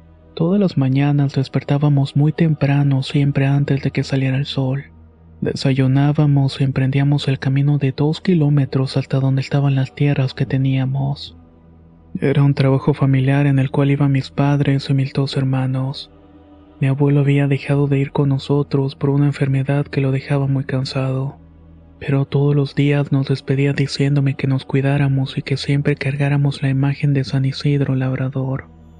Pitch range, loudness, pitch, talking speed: 135-140 Hz, -18 LUFS, 140 Hz, 160 wpm